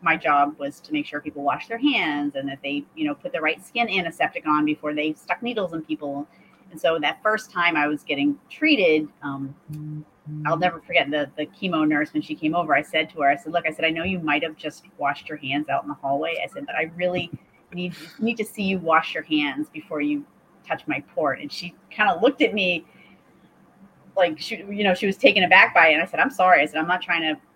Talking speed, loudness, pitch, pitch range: 255 wpm, -22 LUFS, 165 Hz, 150-205 Hz